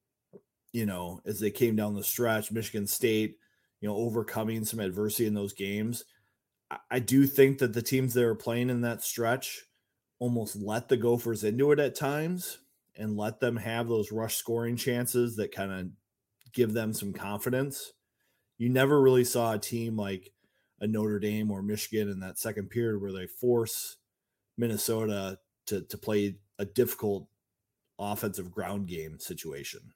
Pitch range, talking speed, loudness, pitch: 105-120 Hz, 165 wpm, -30 LUFS, 110 Hz